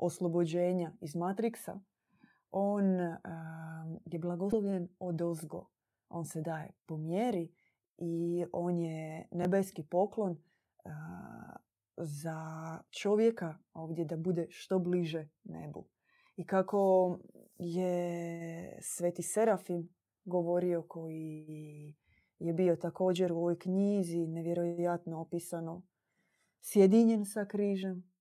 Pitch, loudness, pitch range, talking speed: 175 Hz, -34 LUFS, 165-185 Hz, 100 wpm